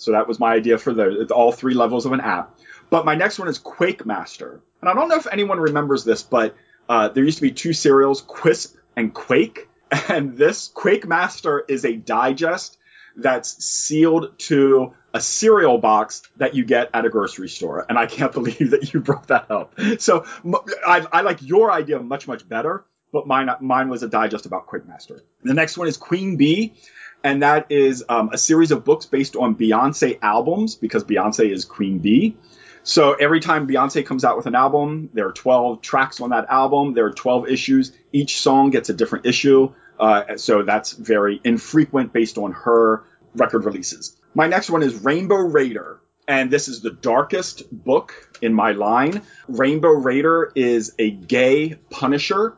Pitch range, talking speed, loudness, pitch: 125-165 Hz, 190 wpm, -19 LUFS, 140 Hz